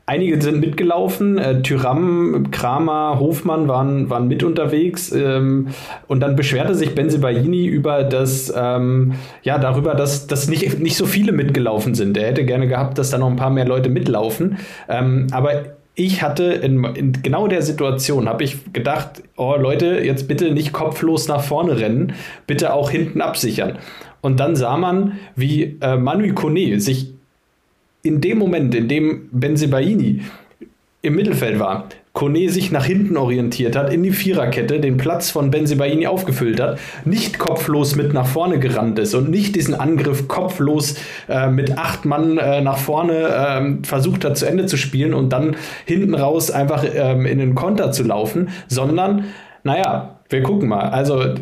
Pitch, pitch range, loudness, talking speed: 145 Hz, 130-165 Hz, -18 LUFS, 165 wpm